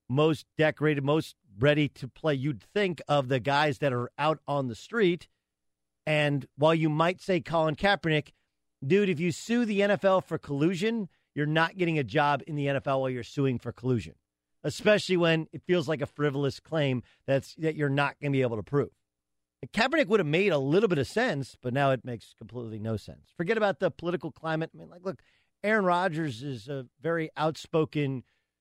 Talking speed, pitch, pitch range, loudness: 195 wpm, 150 Hz, 130-165 Hz, -28 LUFS